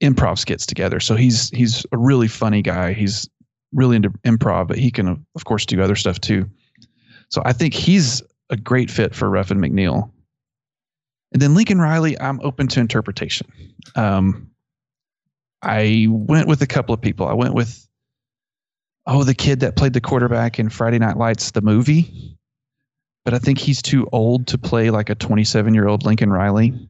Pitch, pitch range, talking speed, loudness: 120 Hz, 110-135 Hz, 180 wpm, -18 LUFS